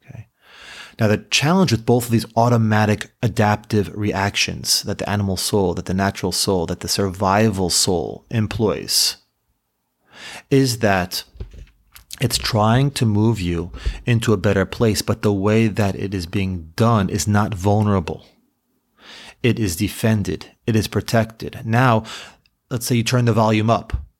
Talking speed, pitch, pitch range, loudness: 145 wpm, 105 Hz, 95-115 Hz, -19 LUFS